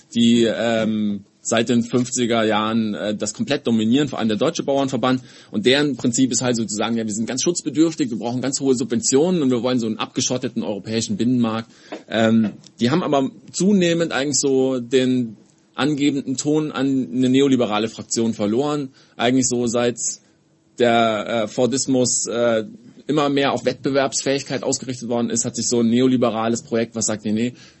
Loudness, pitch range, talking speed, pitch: -20 LUFS, 115-135 Hz, 170 wpm, 125 Hz